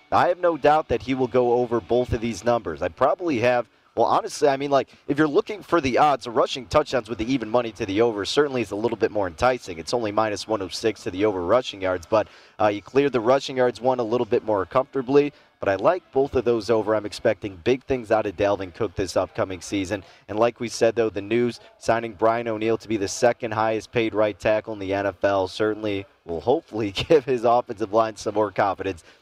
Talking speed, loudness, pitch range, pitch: 235 wpm, -23 LUFS, 110-125 Hz, 115 Hz